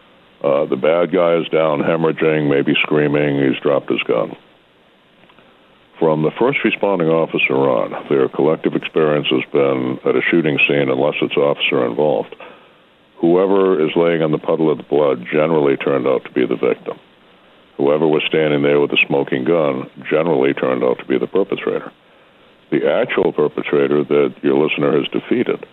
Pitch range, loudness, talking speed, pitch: 65-80 Hz, -16 LUFS, 165 wpm, 75 Hz